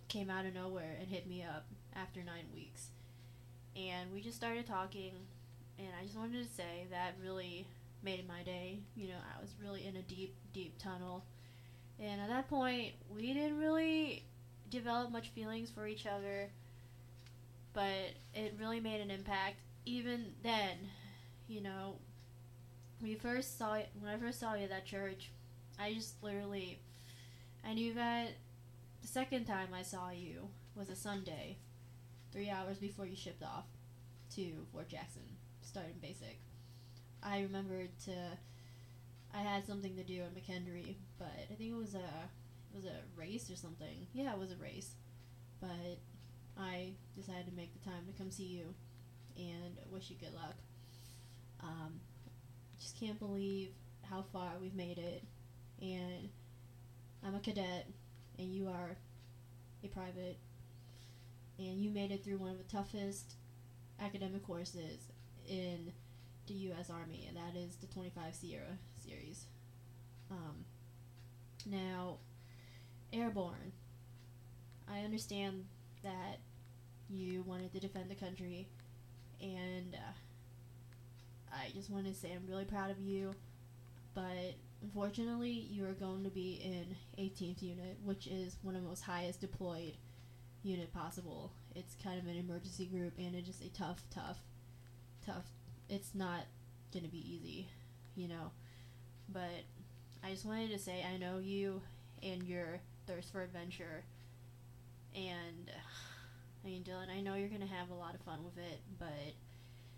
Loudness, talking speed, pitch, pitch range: -46 LUFS, 150 wpm, 175 Hz, 120-190 Hz